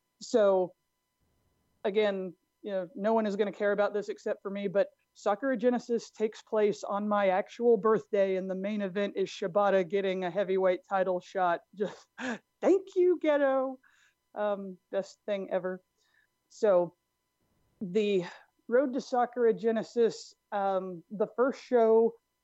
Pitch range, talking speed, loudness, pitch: 190-230 Hz, 140 wpm, -30 LUFS, 205 Hz